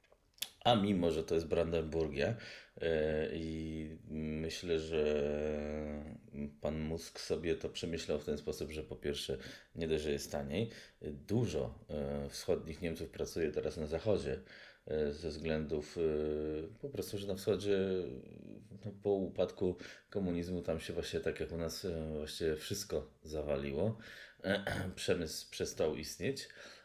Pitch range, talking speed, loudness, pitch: 75-85 Hz, 120 wpm, -38 LUFS, 80 Hz